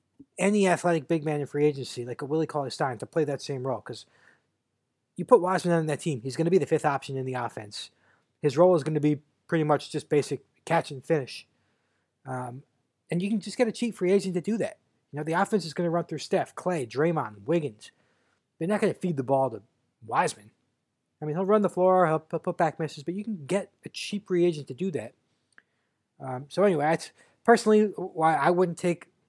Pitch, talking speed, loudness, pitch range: 160 Hz, 230 wpm, -27 LUFS, 140-180 Hz